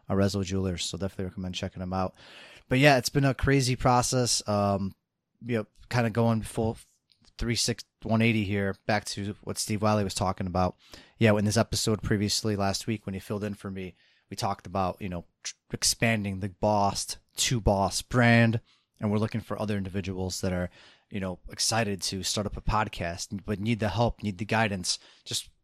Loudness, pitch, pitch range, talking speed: -28 LUFS, 105 Hz, 95-115 Hz, 195 wpm